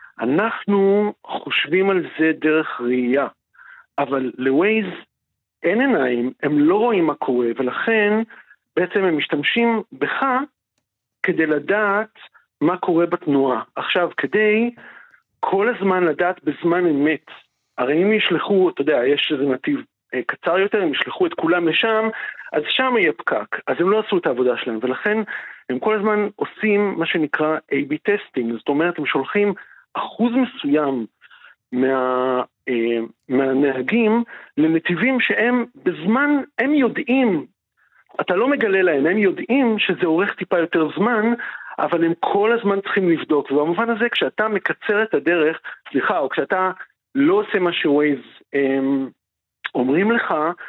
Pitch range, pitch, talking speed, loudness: 145-220 Hz, 180 Hz, 135 wpm, -19 LUFS